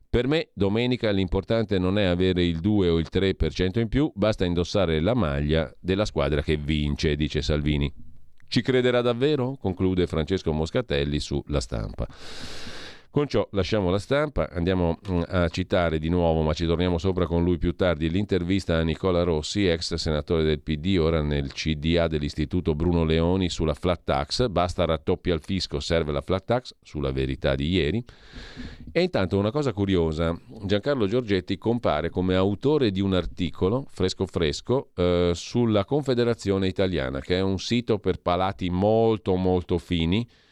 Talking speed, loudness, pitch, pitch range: 160 wpm, -25 LUFS, 90 Hz, 80-100 Hz